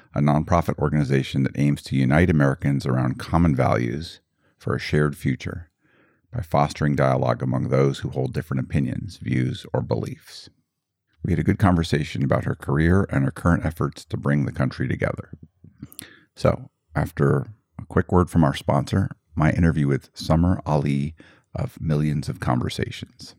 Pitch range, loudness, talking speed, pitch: 70-85 Hz, -23 LUFS, 155 wpm, 75 Hz